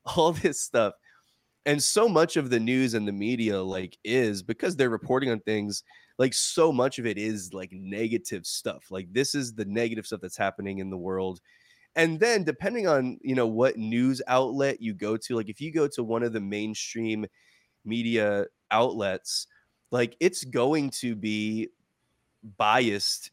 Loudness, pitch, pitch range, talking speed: -27 LUFS, 115 Hz, 105-130 Hz, 175 wpm